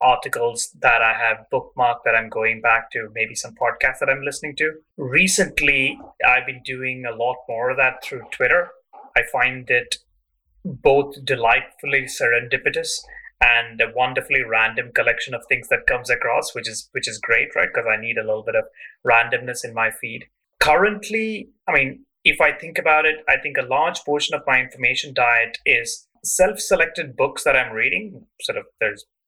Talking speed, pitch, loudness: 180 wpm, 155 Hz, -19 LUFS